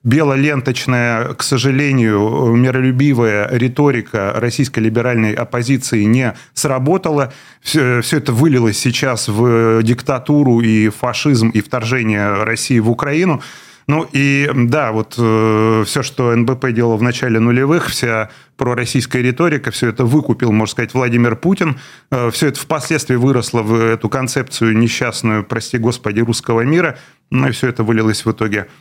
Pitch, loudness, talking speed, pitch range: 125 Hz, -15 LUFS, 135 wpm, 115-135 Hz